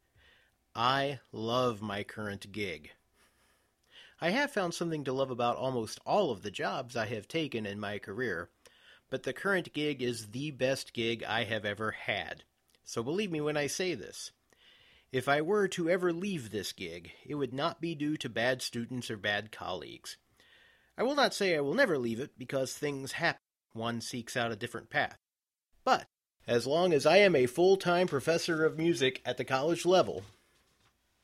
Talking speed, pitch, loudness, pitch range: 185 wpm, 130 Hz, -32 LUFS, 115-165 Hz